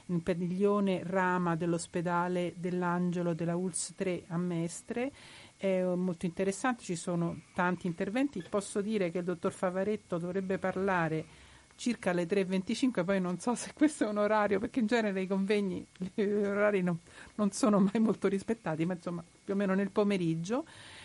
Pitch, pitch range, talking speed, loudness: 190 Hz, 180-205 Hz, 160 wpm, -32 LUFS